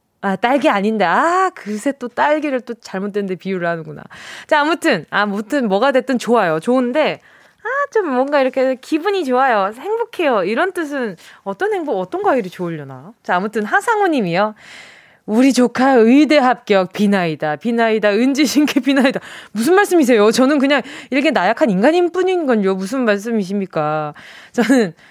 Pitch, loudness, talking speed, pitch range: 250 Hz, -16 LUFS, 350 characters per minute, 205-295 Hz